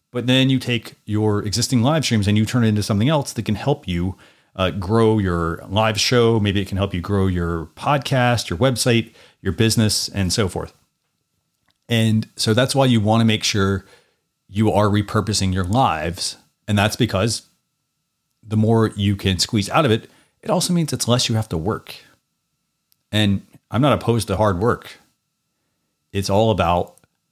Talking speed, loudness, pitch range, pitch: 180 wpm, -19 LUFS, 100-120 Hz, 110 Hz